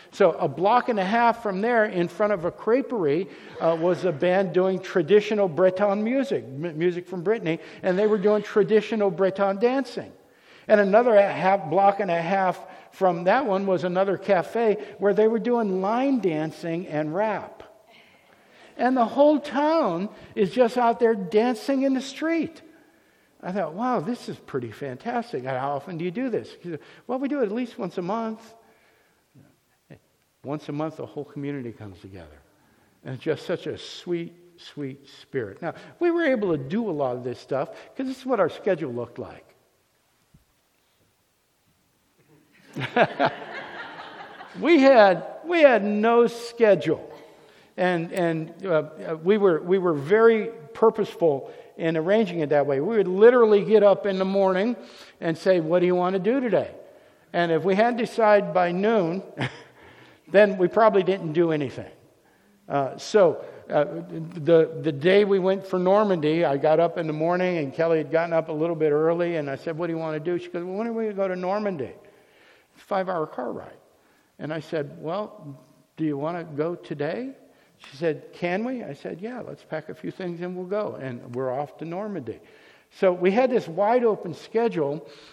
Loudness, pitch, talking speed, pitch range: -23 LUFS, 190 Hz, 180 wpm, 165-220 Hz